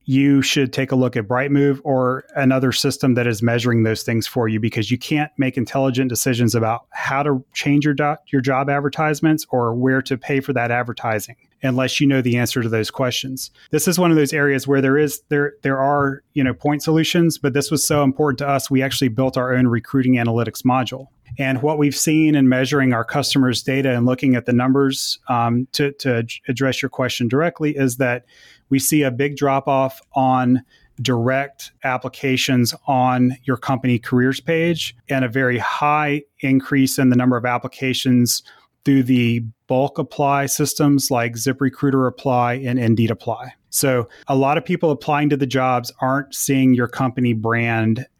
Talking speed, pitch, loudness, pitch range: 185 wpm, 130 Hz, -19 LUFS, 125-140 Hz